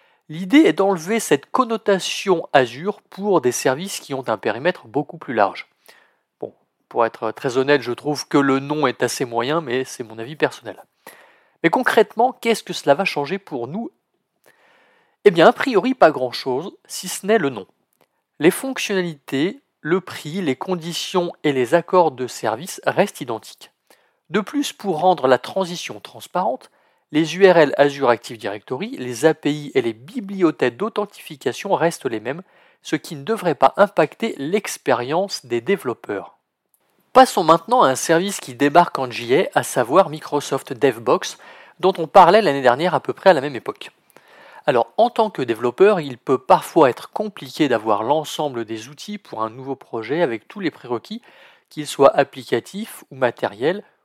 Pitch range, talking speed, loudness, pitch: 135-200 Hz, 165 wpm, -19 LUFS, 165 Hz